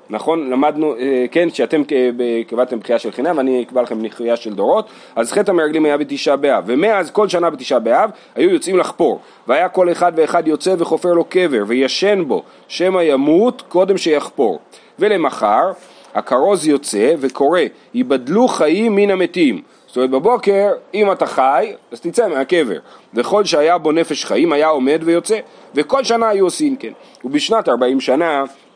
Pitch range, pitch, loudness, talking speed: 135-200 Hz, 170 Hz, -16 LUFS, 155 wpm